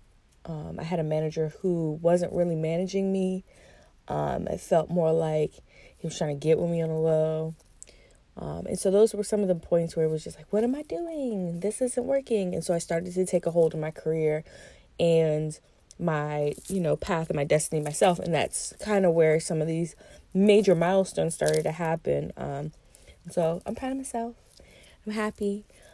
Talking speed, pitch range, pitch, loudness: 200 wpm, 155-190 Hz, 170 Hz, -27 LUFS